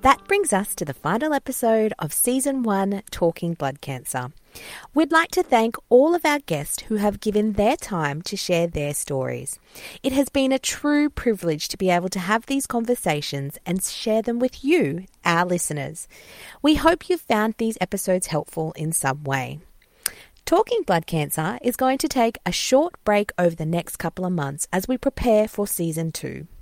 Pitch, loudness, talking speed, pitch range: 205 Hz, -22 LUFS, 185 wpm, 165-260 Hz